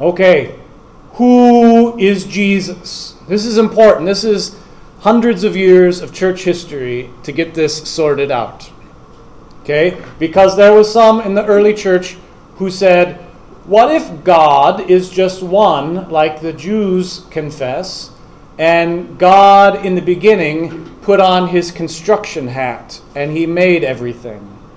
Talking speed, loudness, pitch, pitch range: 135 wpm, -12 LUFS, 185 Hz, 165-205 Hz